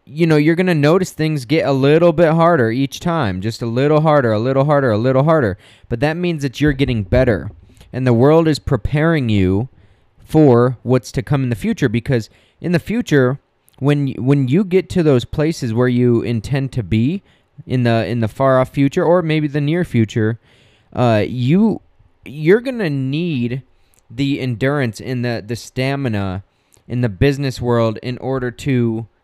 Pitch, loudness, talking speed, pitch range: 130 Hz, -16 LUFS, 185 wpm, 115-150 Hz